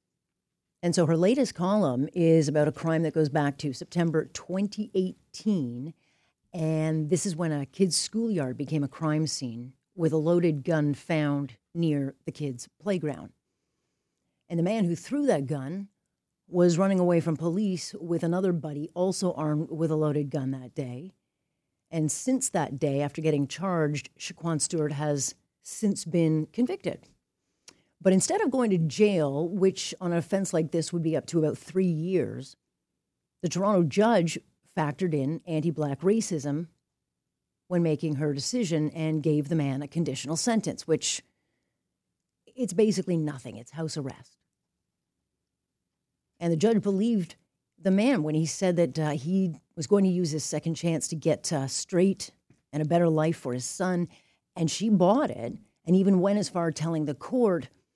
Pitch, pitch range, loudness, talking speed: 165 Hz, 150-185 Hz, -27 LUFS, 165 wpm